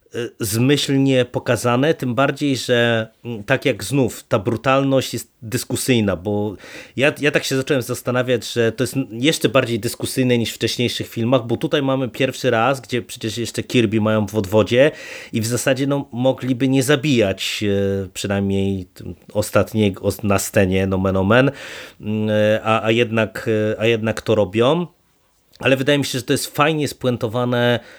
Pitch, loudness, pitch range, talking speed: 120 Hz, -19 LUFS, 110-135 Hz, 150 wpm